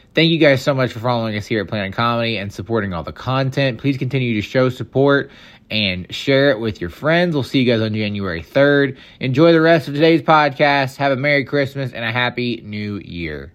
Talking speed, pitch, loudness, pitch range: 220 wpm, 125 Hz, -17 LUFS, 110-140 Hz